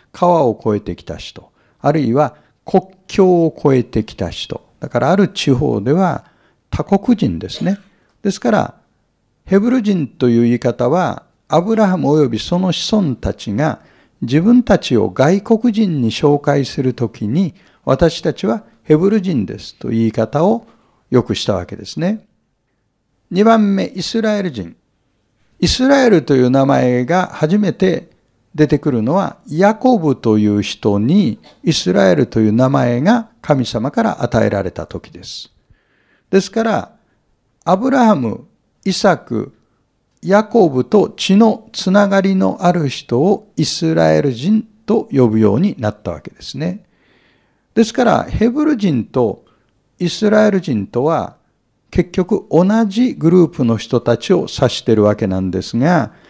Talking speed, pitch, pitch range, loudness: 275 characters per minute, 170 Hz, 120-205 Hz, -15 LUFS